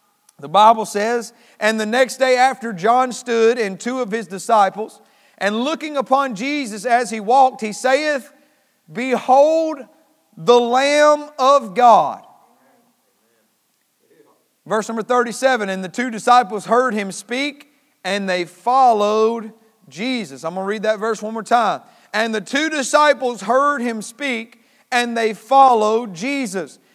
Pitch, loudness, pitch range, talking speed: 235 Hz, -17 LUFS, 215-265 Hz, 140 wpm